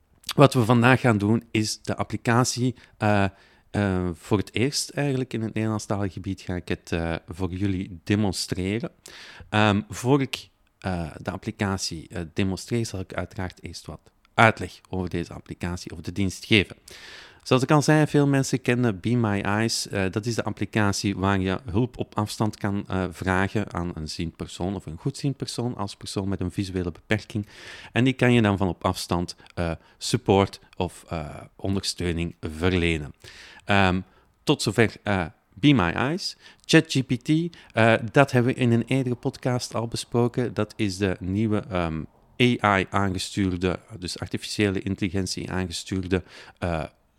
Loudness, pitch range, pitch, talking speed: -25 LUFS, 95-120 Hz, 105 Hz, 160 wpm